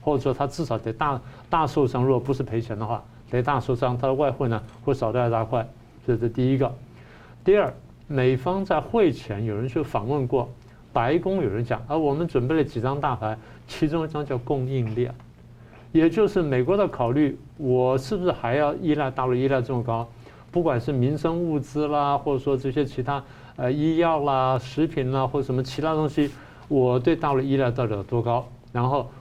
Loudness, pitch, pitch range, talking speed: -24 LUFS, 135 Hz, 120-150 Hz, 290 characters per minute